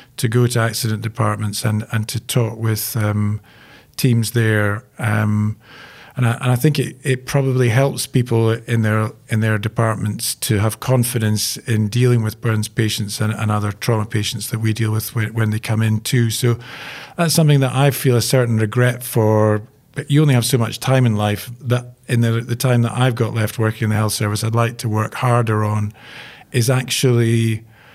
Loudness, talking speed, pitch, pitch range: -18 LUFS, 200 wpm, 115 Hz, 110-125 Hz